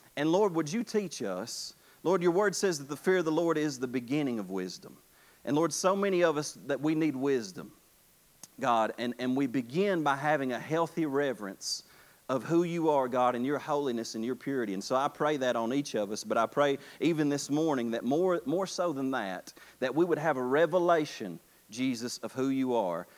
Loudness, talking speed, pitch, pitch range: -30 LUFS, 215 wpm, 145 Hz, 125-165 Hz